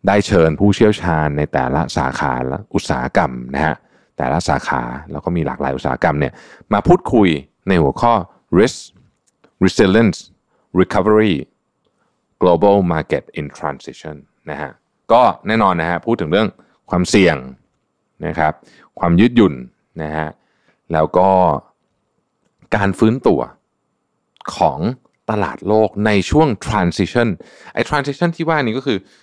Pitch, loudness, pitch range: 95 Hz, -16 LUFS, 75-110 Hz